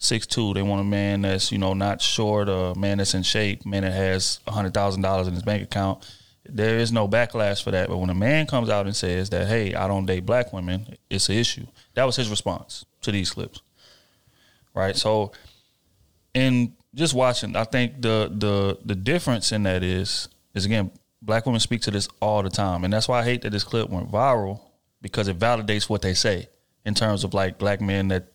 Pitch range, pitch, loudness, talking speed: 95-115 Hz, 100 Hz, -24 LUFS, 225 wpm